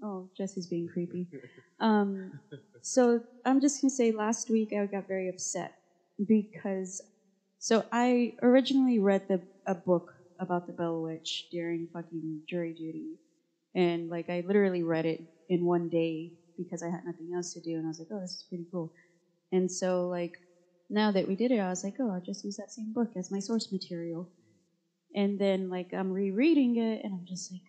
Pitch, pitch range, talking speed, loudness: 185 Hz, 170-205 Hz, 195 wpm, -31 LUFS